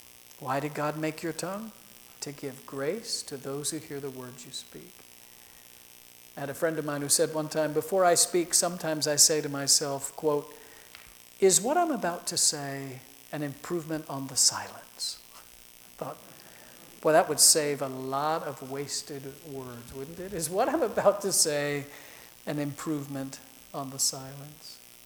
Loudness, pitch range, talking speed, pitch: -27 LUFS, 135-155 Hz, 170 wpm, 145 Hz